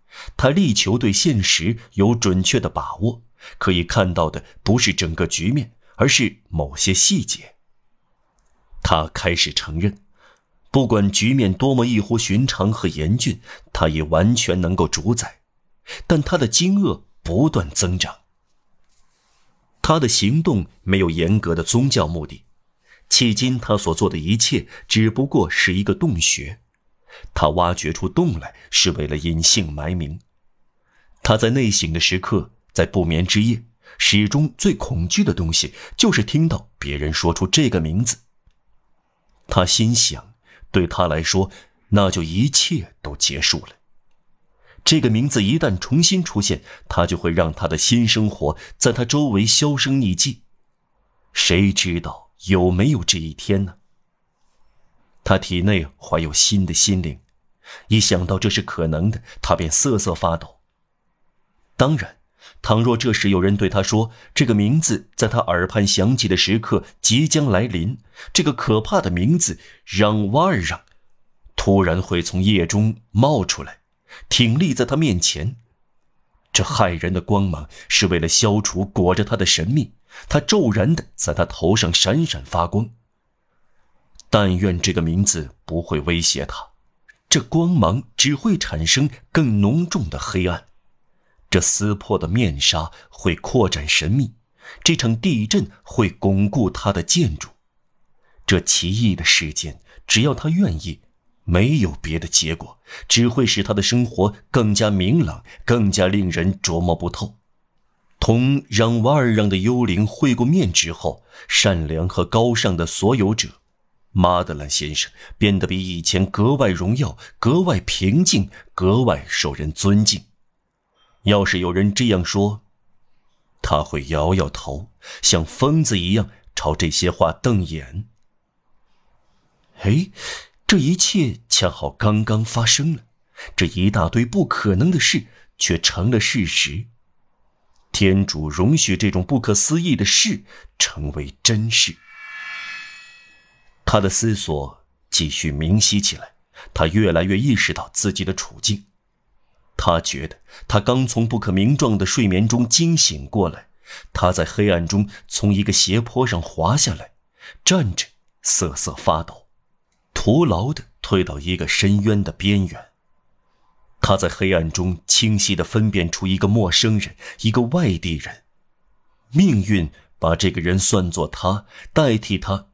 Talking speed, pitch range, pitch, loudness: 205 characters per minute, 90-115 Hz, 100 Hz, -18 LUFS